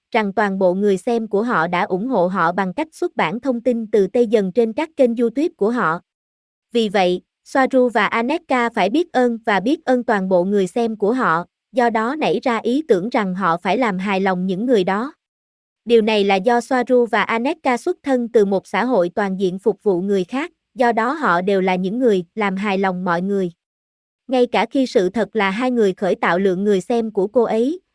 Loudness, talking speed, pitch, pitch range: -18 LUFS, 225 wpm, 220 Hz, 190-245 Hz